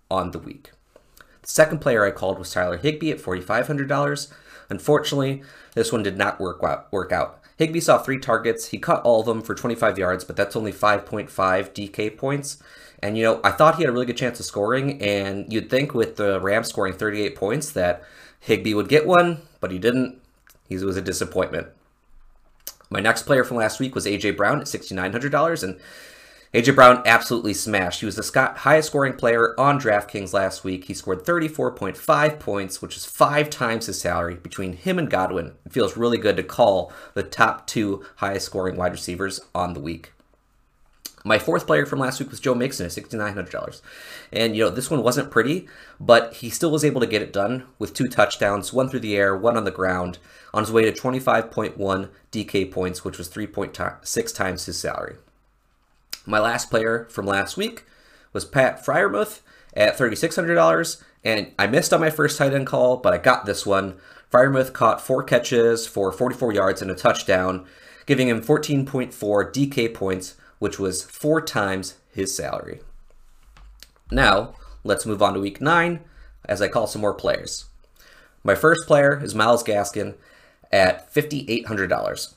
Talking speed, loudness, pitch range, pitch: 180 wpm, -22 LUFS, 100-135 Hz, 115 Hz